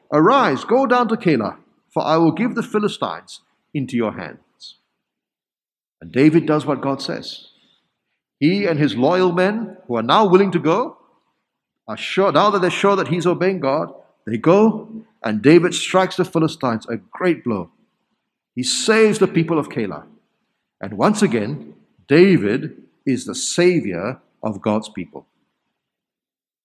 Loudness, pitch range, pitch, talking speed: -18 LUFS, 130-200 Hz, 170 Hz, 150 wpm